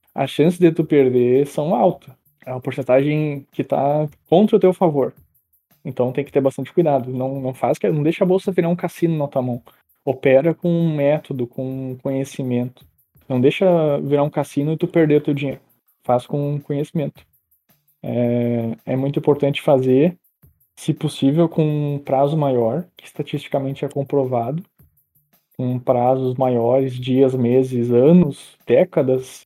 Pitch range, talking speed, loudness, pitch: 130-155 Hz, 160 wpm, -19 LUFS, 140 Hz